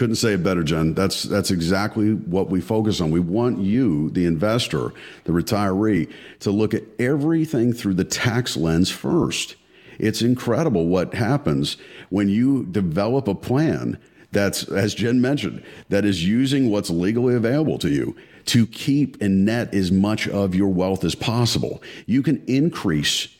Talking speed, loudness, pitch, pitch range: 160 wpm, -21 LUFS, 105 Hz, 95-120 Hz